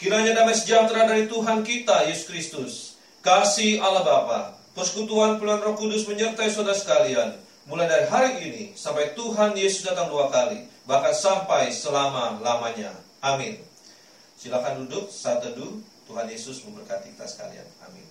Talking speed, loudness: 140 wpm, -23 LUFS